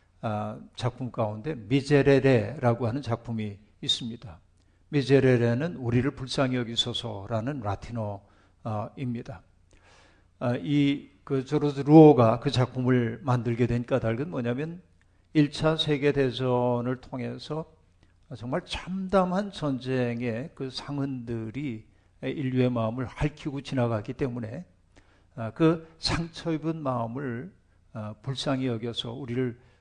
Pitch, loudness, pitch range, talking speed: 125 Hz, -27 LUFS, 110-140 Hz, 250 characters per minute